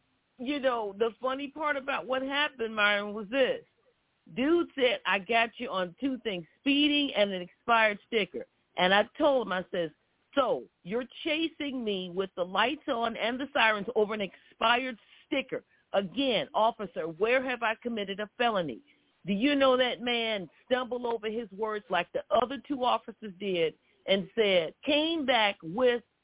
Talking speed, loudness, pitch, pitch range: 165 wpm, -29 LUFS, 230 Hz, 205-270 Hz